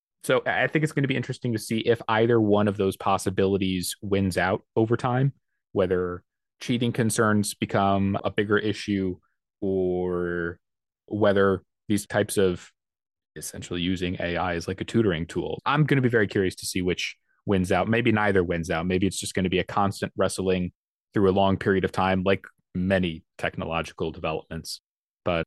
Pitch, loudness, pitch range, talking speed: 100 Hz, -25 LUFS, 90-110 Hz, 175 wpm